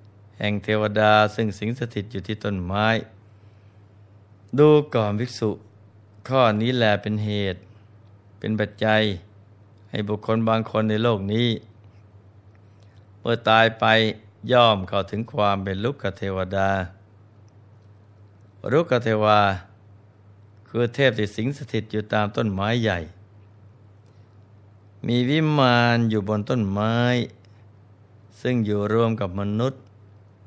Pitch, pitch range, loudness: 105 Hz, 100-110 Hz, -22 LUFS